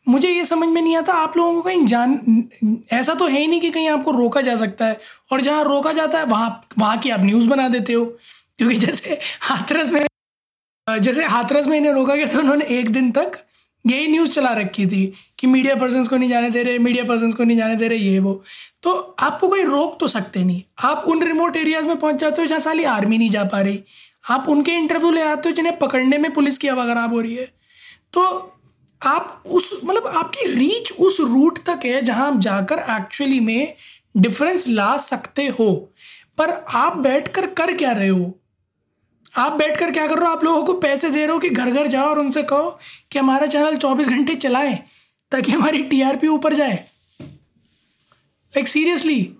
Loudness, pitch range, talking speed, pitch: -18 LUFS, 240-315 Hz, 210 wpm, 280 Hz